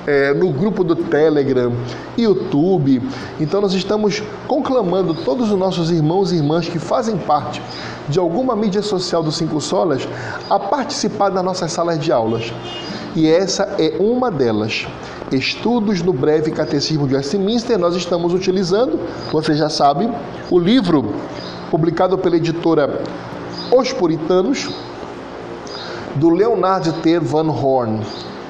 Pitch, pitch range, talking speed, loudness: 170 Hz, 150-200 Hz, 130 wpm, -17 LUFS